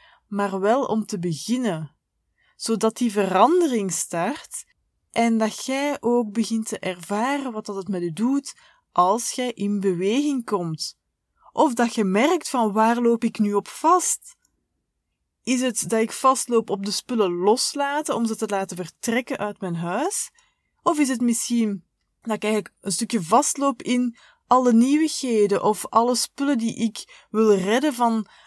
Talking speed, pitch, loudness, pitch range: 160 wpm, 230 Hz, -22 LUFS, 205-260 Hz